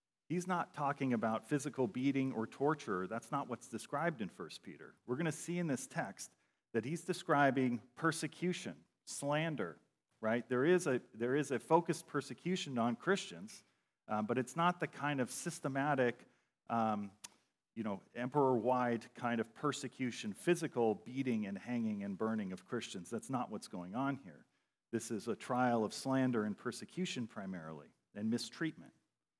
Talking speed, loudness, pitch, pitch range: 160 wpm, -38 LUFS, 135 Hz, 115-165 Hz